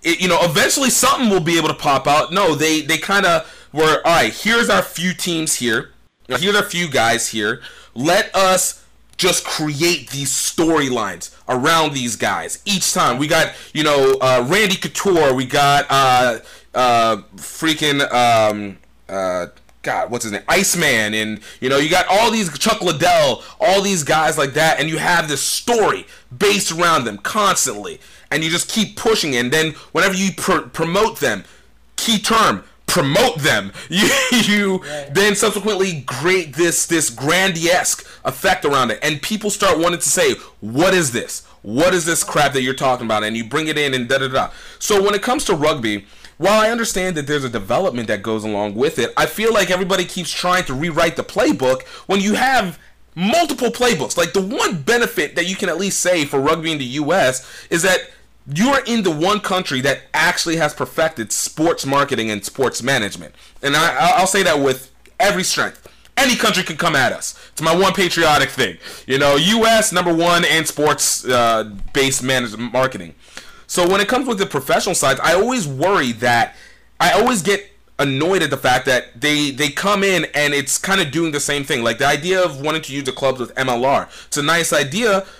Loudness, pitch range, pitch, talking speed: -16 LUFS, 135-190 Hz, 160 Hz, 195 wpm